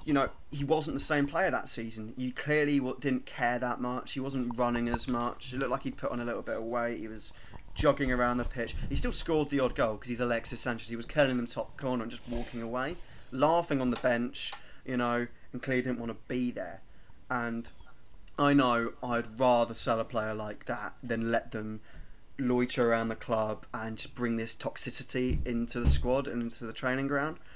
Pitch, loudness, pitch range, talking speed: 120 Hz, -32 LUFS, 115-130 Hz, 220 wpm